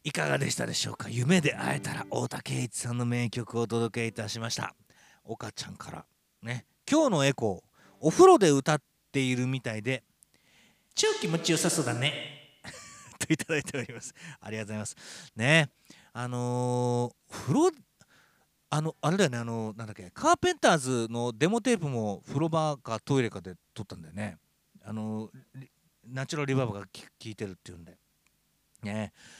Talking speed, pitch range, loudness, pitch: 345 characters per minute, 110-150 Hz, -29 LUFS, 125 Hz